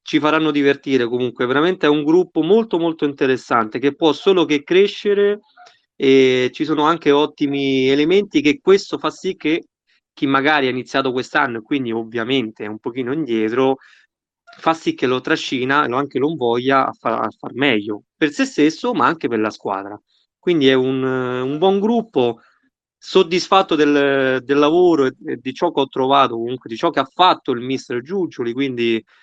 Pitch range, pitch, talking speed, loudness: 130-170 Hz, 145 Hz, 180 wpm, -18 LUFS